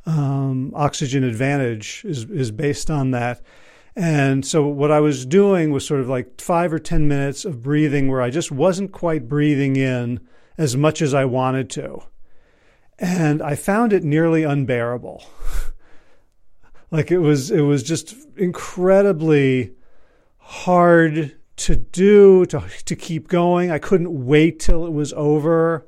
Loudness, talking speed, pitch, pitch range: -18 LUFS, 150 wpm, 150 Hz, 135-170 Hz